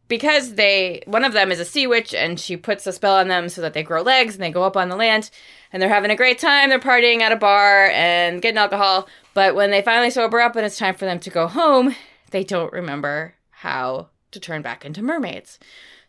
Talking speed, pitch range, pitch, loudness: 240 wpm, 175-230 Hz, 195 Hz, -17 LUFS